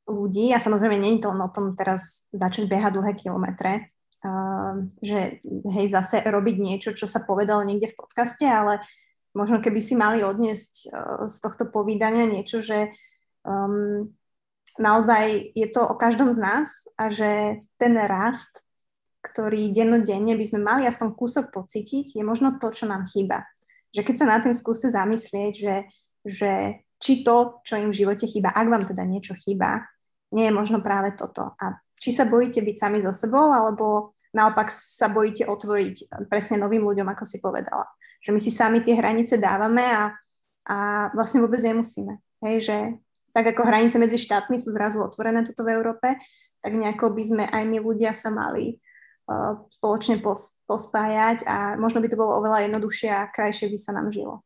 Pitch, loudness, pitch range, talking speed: 215 Hz, -23 LUFS, 205-230 Hz, 175 wpm